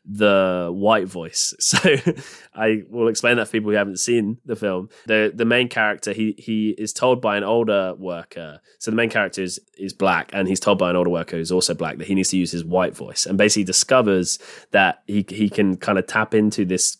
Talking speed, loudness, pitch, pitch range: 230 wpm, -20 LUFS, 100 Hz, 90-110 Hz